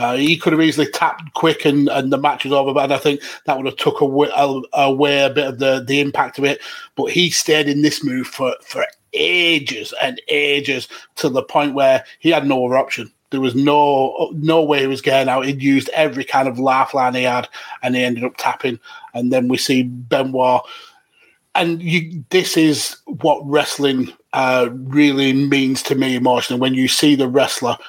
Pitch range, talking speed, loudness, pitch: 130-150 Hz, 205 wpm, -17 LUFS, 140 Hz